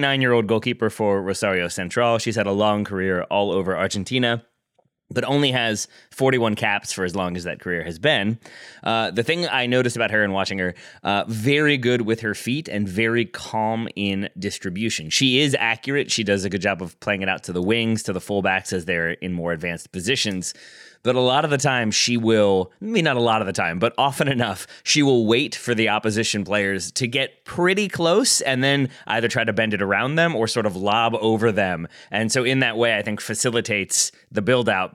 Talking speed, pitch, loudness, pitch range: 215 wpm, 110 Hz, -21 LUFS, 100-125 Hz